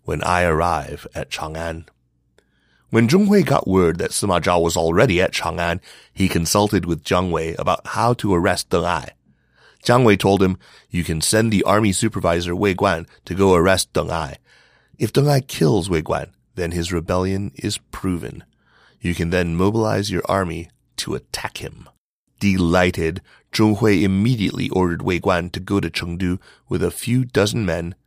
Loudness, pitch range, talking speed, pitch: -19 LUFS, 85-105 Hz, 170 wpm, 95 Hz